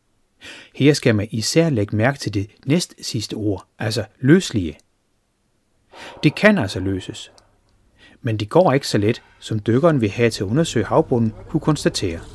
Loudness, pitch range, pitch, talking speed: -19 LUFS, 105-150 Hz, 115 Hz, 160 wpm